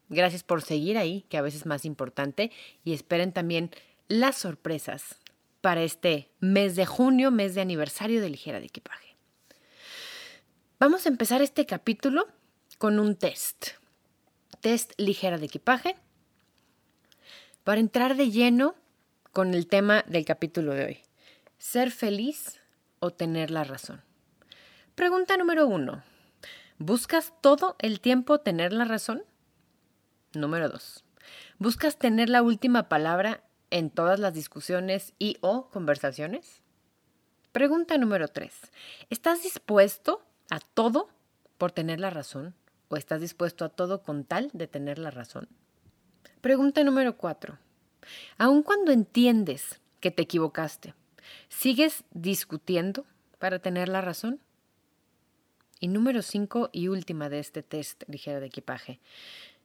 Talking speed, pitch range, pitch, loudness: 130 wpm, 165-255 Hz, 195 Hz, -27 LUFS